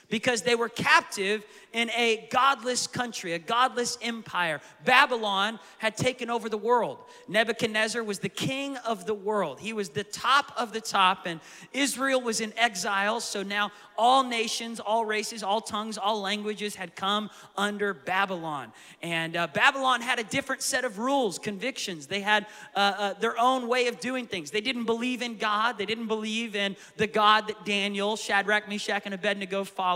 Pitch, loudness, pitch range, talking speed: 215 Hz, -27 LUFS, 200-240 Hz, 175 wpm